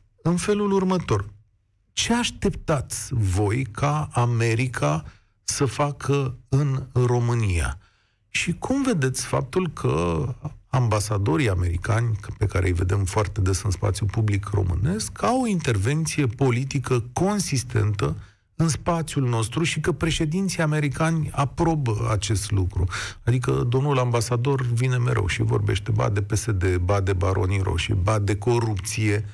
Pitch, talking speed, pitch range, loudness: 120 Hz, 125 wpm, 105-145 Hz, -24 LUFS